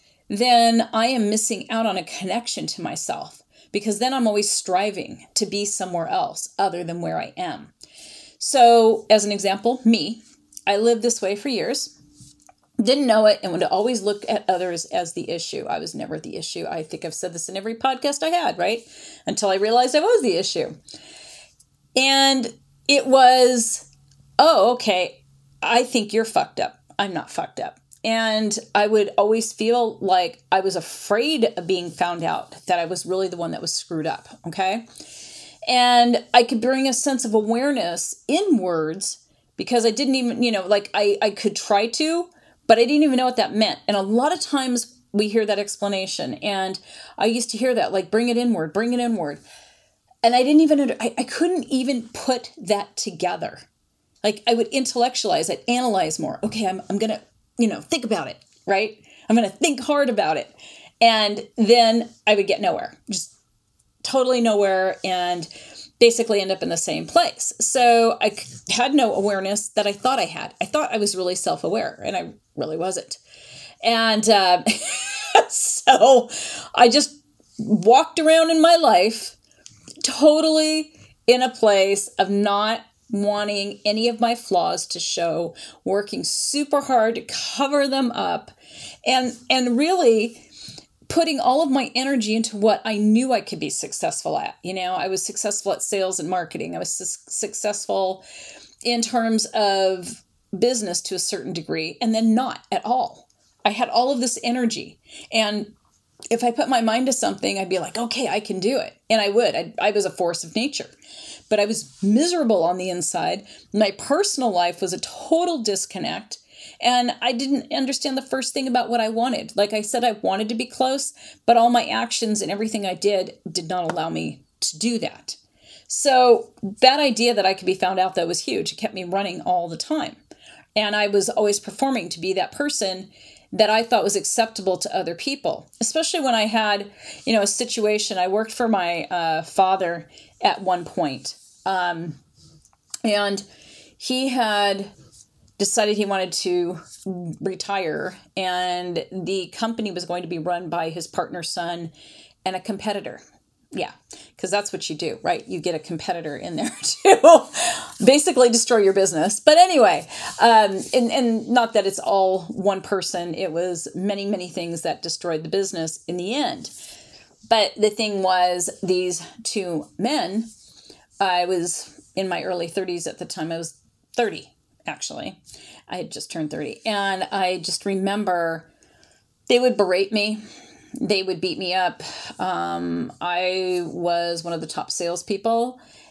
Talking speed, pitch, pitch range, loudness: 175 wpm, 215 Hz, 185-245 Hz, -21 LUFS